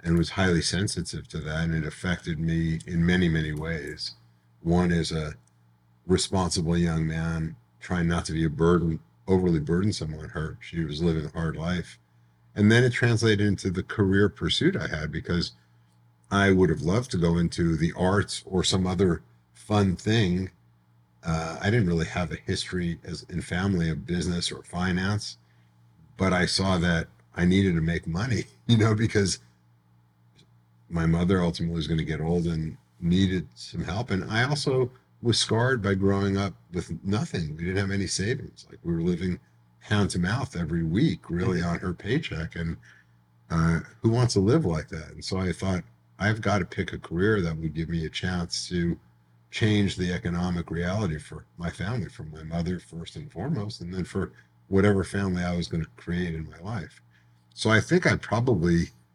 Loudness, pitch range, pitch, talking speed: -26 LUFS, 80-95 Hz, 85 Hz, 185 wpm